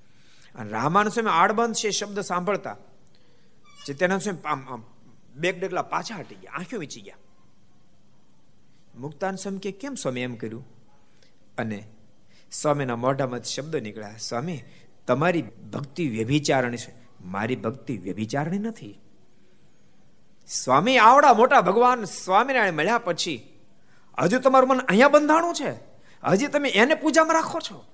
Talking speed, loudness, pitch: 120 wpm, -22 LUFS, 165 Hz